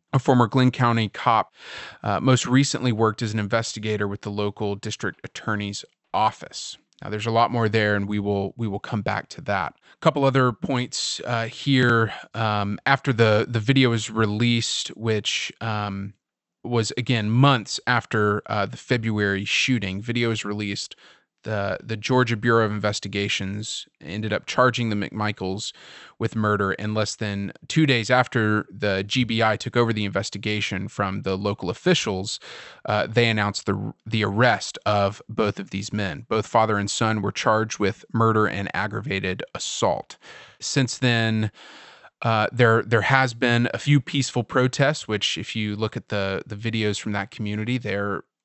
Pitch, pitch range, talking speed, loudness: 110 Hz, 100-120 Hz, 165 wpm, -23 LUFS